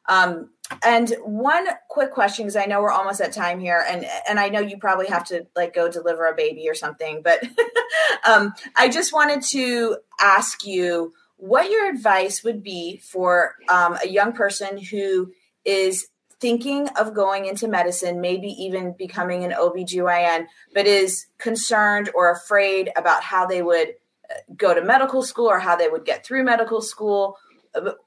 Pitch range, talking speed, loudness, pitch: 180-235 Hz, 170 wpm, -20 LUFS, 200 Hz